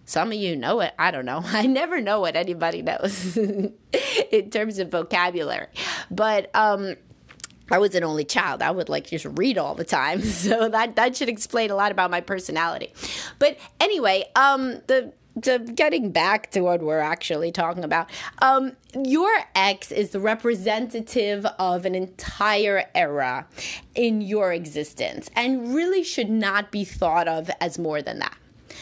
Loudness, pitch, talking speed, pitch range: -23 LUFS, 205 Hz, 165 wpm, 180-235 Hz